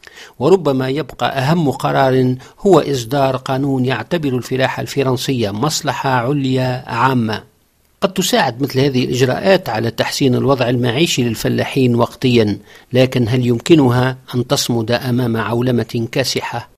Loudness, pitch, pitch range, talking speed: -16 LUFS, 130 Hz, 125-140 Hz, 115 wpm